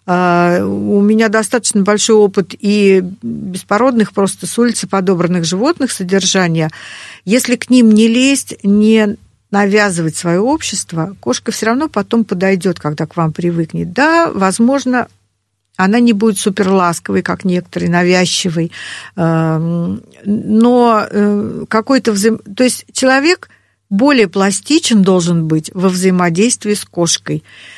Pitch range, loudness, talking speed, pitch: 175-225 Hz, -13 LUFS, 120 wpm, 200 Hz